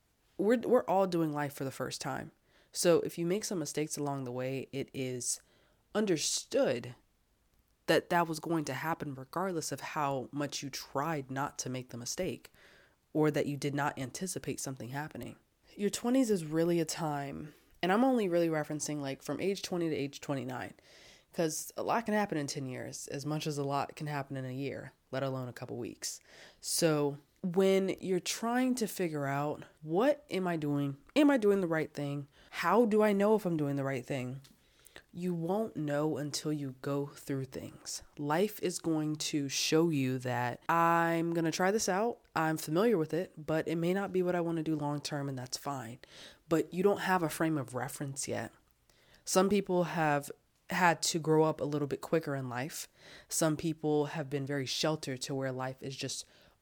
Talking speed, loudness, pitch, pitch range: 200 wpm, -33 LUFS, 150 Hz, 135-175 Hz